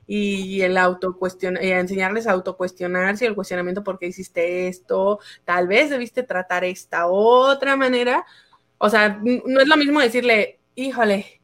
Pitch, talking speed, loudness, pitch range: 195 Hz, 145 wpm, -20 LUFS, 180-240 Hz